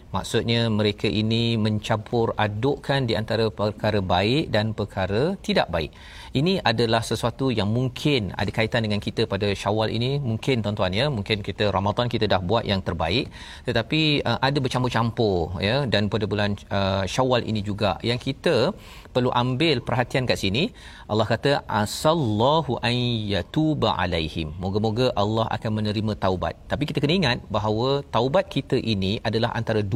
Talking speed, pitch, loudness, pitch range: 150 wpm, 110 Hz, -23 LUFS, 105-125 Hz